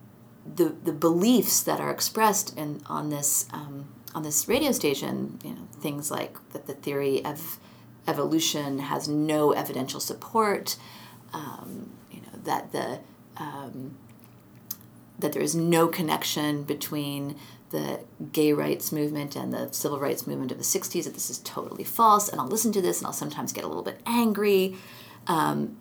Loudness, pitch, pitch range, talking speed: -27 LUFS, 150 Hz, 135-170 Hz, 165 wpm